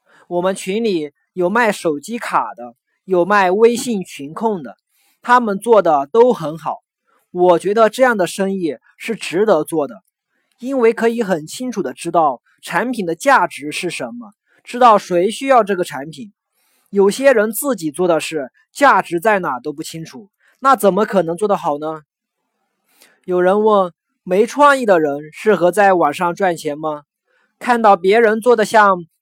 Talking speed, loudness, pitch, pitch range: 230 characters per minute, -16 LUFS, 195 Hz, 165-225 Hz